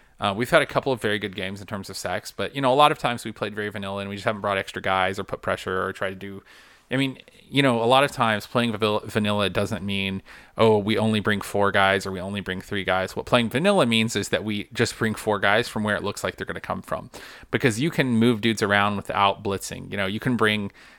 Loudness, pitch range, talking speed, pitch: -23 LUFS, 100-120 Hz, 275 wpm, 105 Hz